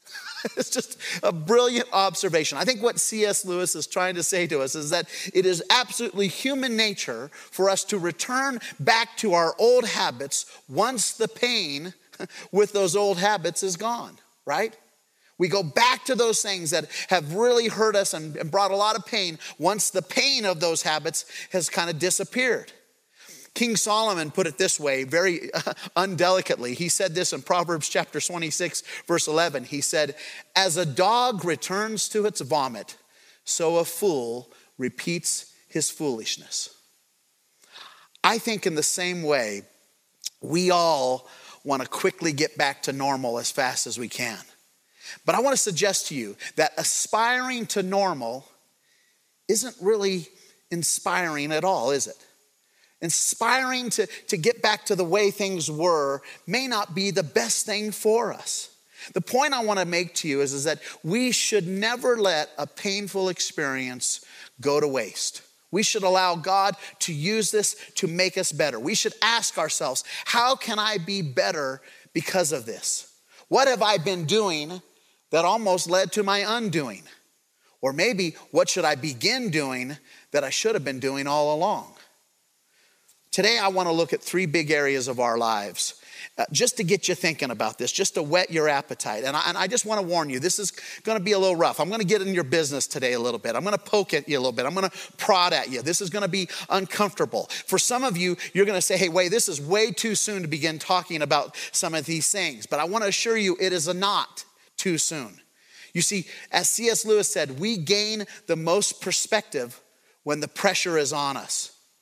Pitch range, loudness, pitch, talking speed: 160-210 Hz, -24 LUFS, 185 Hz, 190 wpm